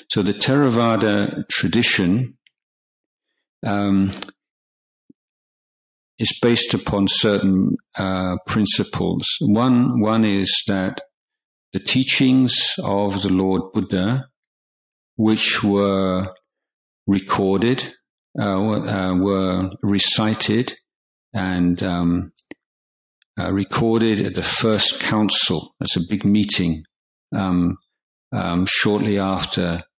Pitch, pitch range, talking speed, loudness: 100 Hz, 95-110 Hz, 90 wpm, -19 LUFS